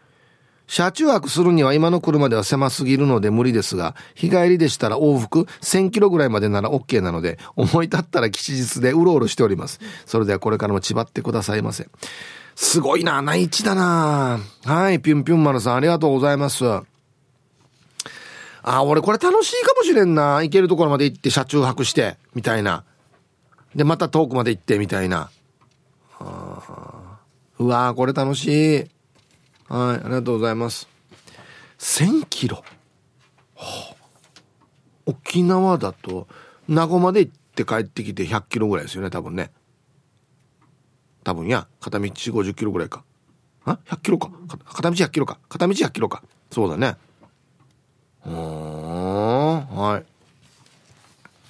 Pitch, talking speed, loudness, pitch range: 135 Hz, 295 characters per minute, -20 LUFS, 120-160 Hz